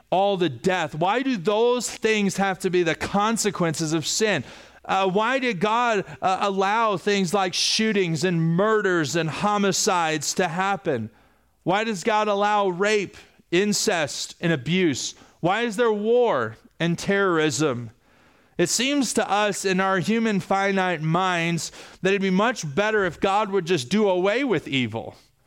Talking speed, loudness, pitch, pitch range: 155 wpm, -22 LUFS, 195 Hz, 170-210 Hz